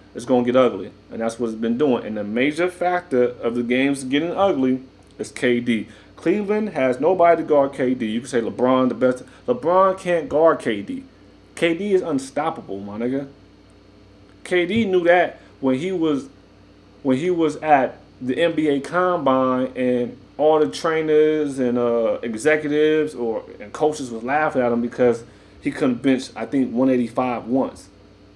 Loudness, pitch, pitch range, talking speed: -20 LUFS, 130 Hz, 115-155 Hz, 165 wpm